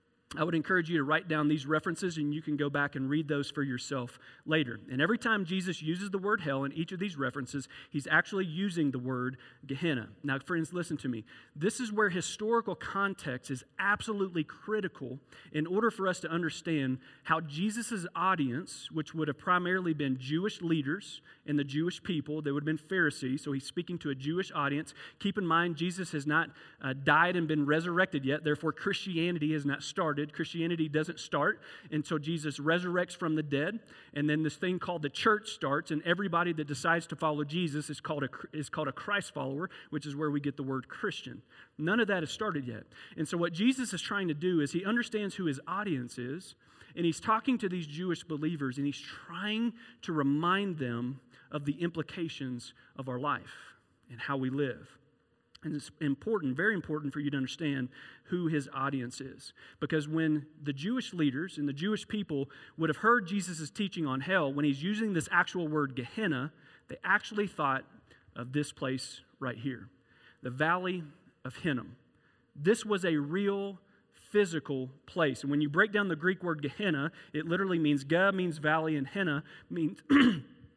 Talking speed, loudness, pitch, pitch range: 190 wpm, -32 LUFS, 155 Hz, 140-180 Hz